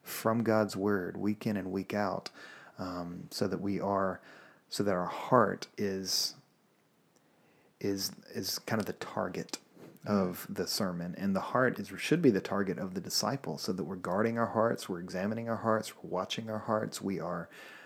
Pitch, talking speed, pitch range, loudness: 100 Hz, 180 wpm, 95-110 Hz, -33 LUFS